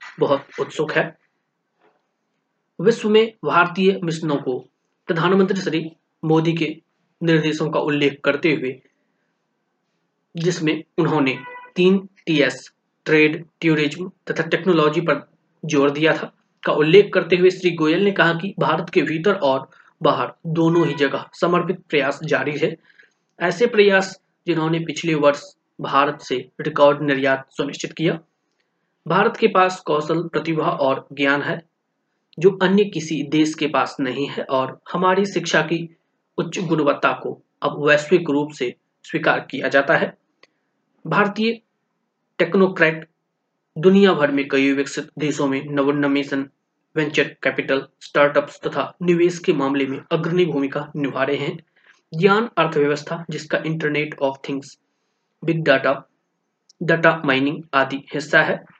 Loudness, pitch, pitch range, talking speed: -20 LUFS, 160 Hz, 145-180 Hz, 125 wpm